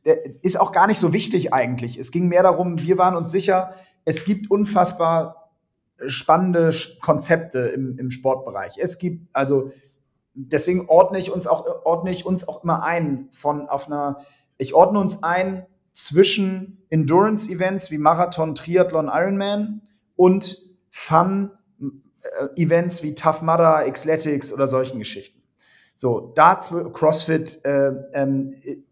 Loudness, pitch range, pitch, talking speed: -20 LUFS, 145-185 Hz, 165 Hz, 135 wpm